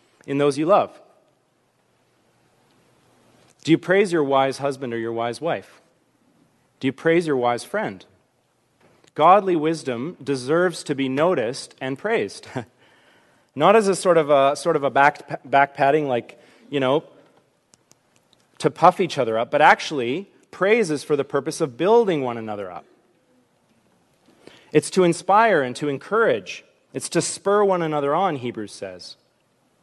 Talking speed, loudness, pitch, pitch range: 145 wpm, -21 LUFS, 150 Hz, 135-175 Hz